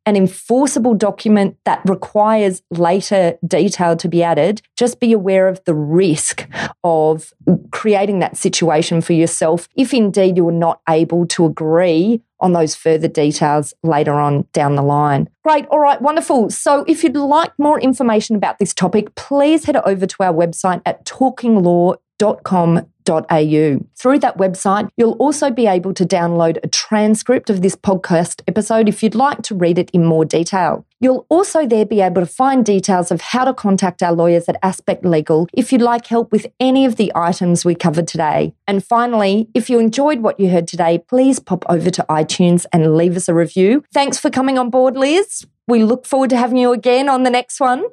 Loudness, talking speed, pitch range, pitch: -15 LUFS, 190 wpm, 170-245 Hz, 195 Hz